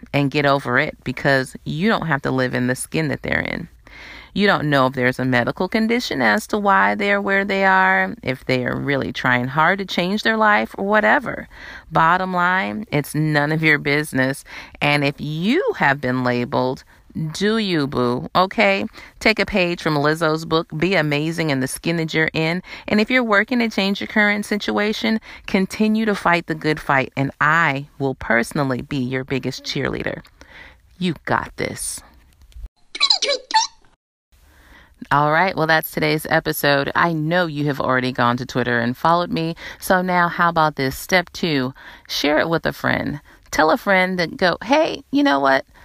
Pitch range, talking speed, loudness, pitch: 135-195 Hz, 180 wpm, -19 LUFS, 160 Hz